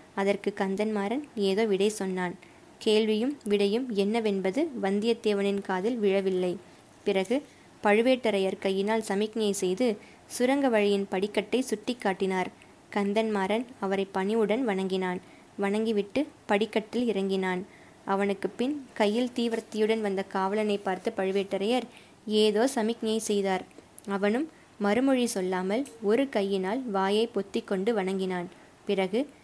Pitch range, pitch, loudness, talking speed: 195-225 Hz, 205 Hz, -28 LUFS, 100 wpm